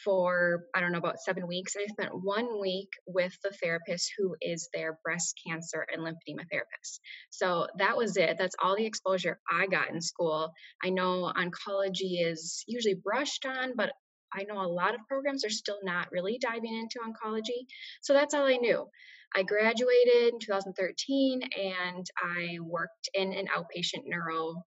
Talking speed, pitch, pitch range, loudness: 175 wpm, 190 Hz, 175-225 Hz, -31 LUFS